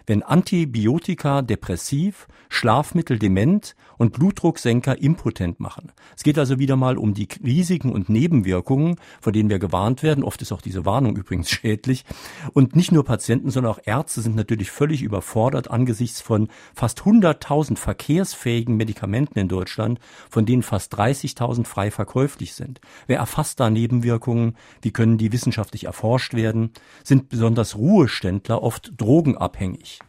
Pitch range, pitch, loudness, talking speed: 110-140 Hz, 120 Hz, -21 LUFS, 145 wpm